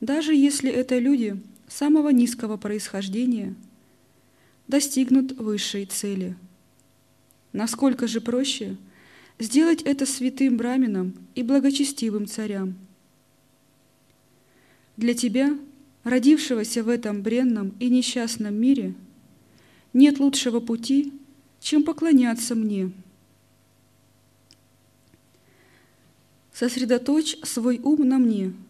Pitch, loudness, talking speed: 230 Hz, -23 LUFS, 85 wpm